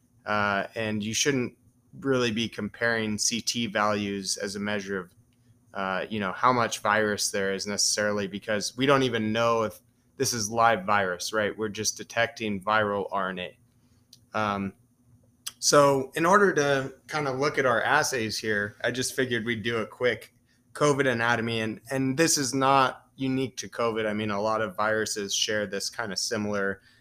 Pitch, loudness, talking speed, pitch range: 115 Hz, -26 LUFS, 175 wpm, 105-125 Hz